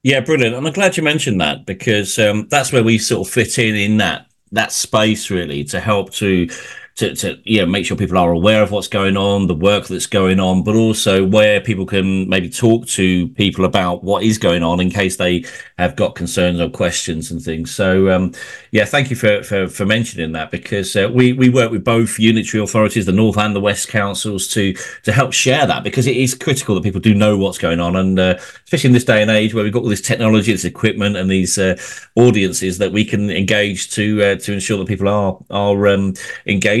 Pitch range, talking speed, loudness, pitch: 95-110 Hz, 230 wpm, -15 LUFS, 105 Hz